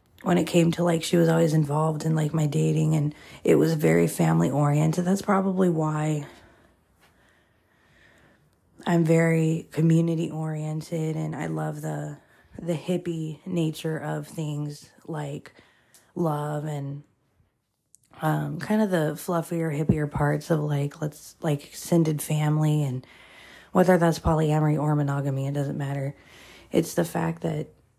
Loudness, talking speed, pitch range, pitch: -25 LUFS, 135 wpm, 140-165 Hz, 155 Hz